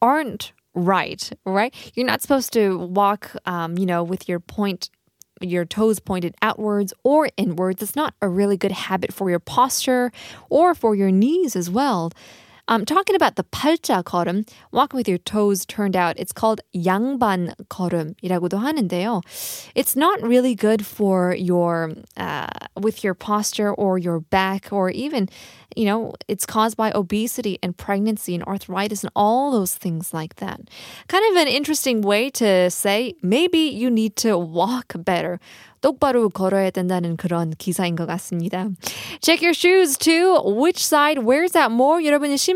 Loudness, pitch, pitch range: -20 LUFS, 205 Hz, 185-250 Hz